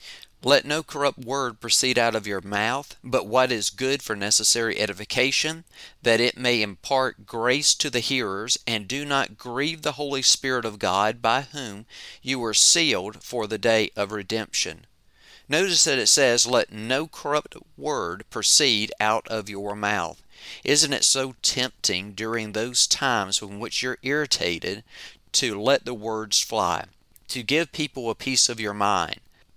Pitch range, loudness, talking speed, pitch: 105-130 Hz, -22 LUFS, 160 wpm, 115 Hz